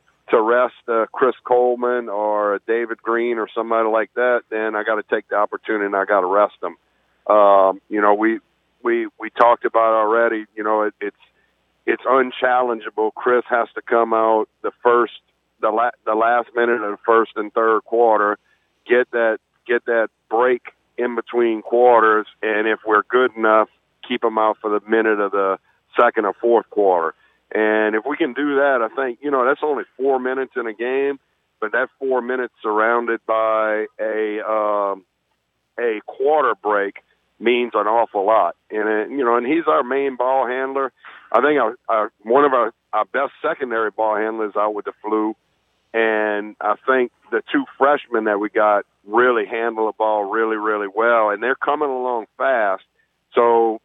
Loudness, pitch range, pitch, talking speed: -19 LUFS, 105-120 Hz, 110 Hz, 185 wpm